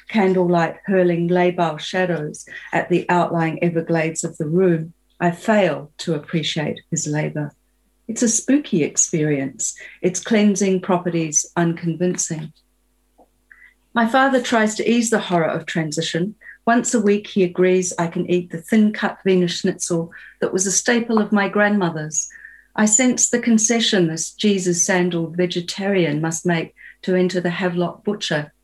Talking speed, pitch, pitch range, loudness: 140 wpm, 180 Hz, 165-205 Hz, -19 LUFS